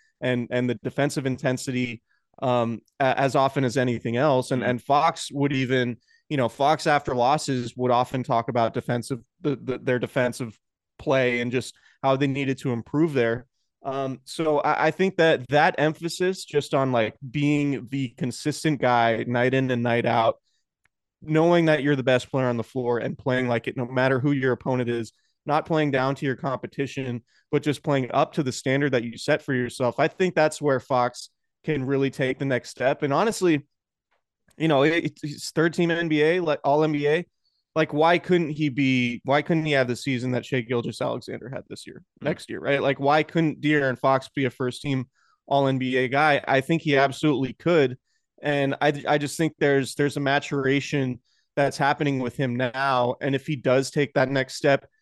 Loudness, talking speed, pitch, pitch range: -24 LUFS, 195 wpm, 135 Hz, 125-150 Hz